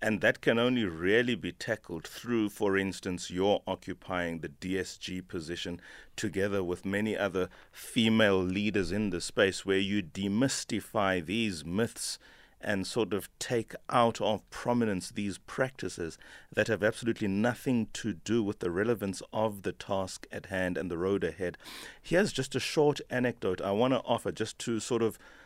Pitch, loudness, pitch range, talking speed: 105 Hz, -31 LUFS, 95-115 Hz, 165 wpm